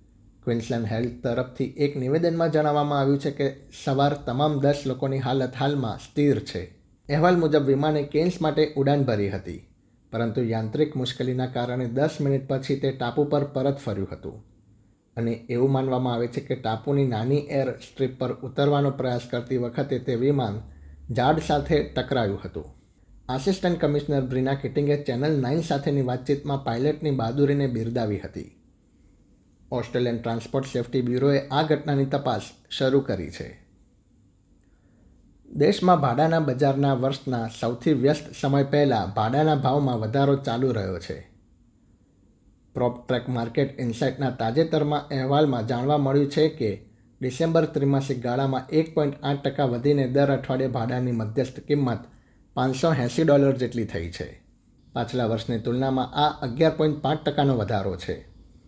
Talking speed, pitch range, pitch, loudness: 135 wpm, 115-145 Hz, 130 Hz, -25 LUFS